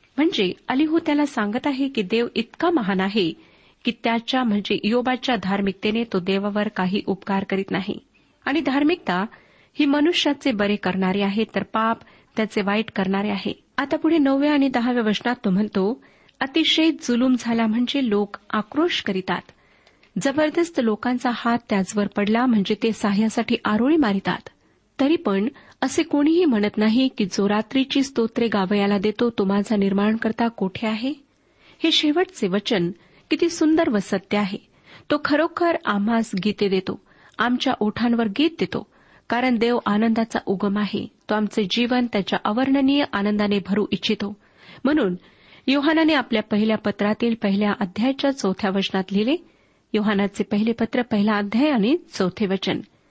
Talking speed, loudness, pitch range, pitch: 140 wpm, -22 LUFS, 205-270 Hz, 225 Hz